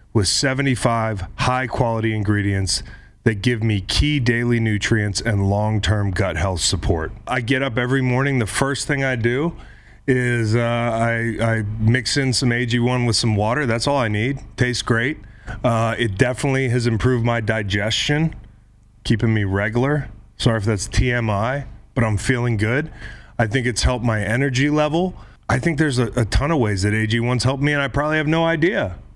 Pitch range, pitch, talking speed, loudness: 110-130 Hz, 115 Hz, 180 wpm, -20 LUFS